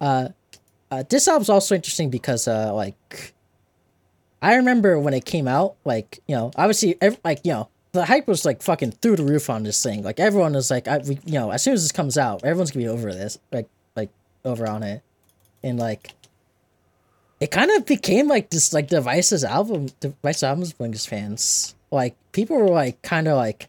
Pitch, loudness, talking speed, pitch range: 135 Hz, -21 LUFS, 205 wpm, 110-175 Hz